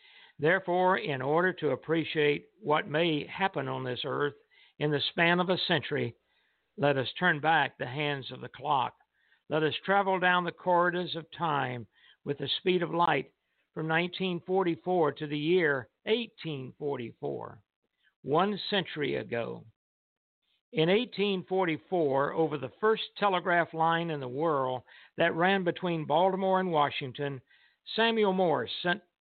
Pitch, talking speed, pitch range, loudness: 165 Hz, 140 wpm, 145-185 Hz, -29 LUFS